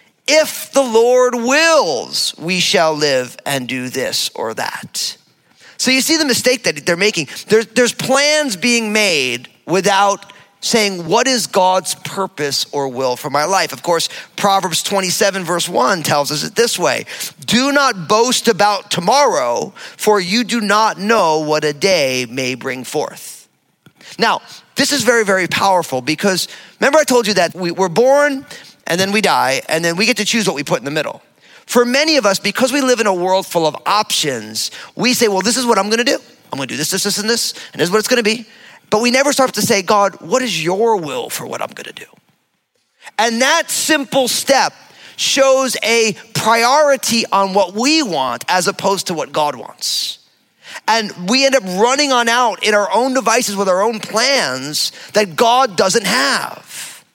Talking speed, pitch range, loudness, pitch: 195 wpm, 180-245 Hz, -15 LUFS, 210 Hz